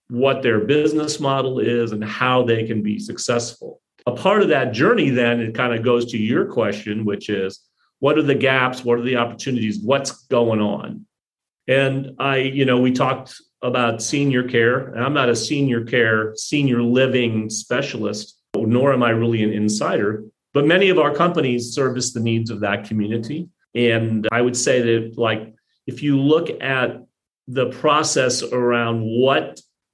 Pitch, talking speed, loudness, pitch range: 120 Hz, 170 wpm, -19 LUFS, 115-135 Hz